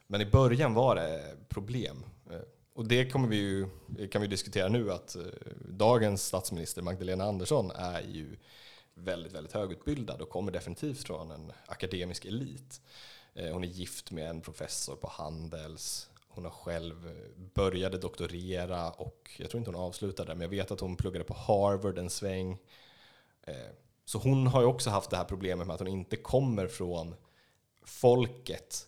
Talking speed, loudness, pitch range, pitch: 160 wpm, -33 LUFS, 90-115 Hz, 95 Hz